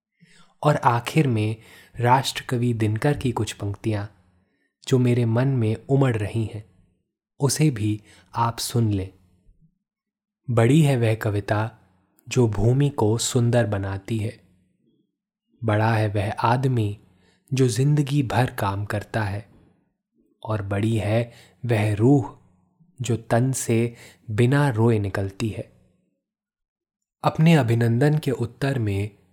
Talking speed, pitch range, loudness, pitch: 115 wpm, 105-130 Hz, -23 LUFS, 115 Hz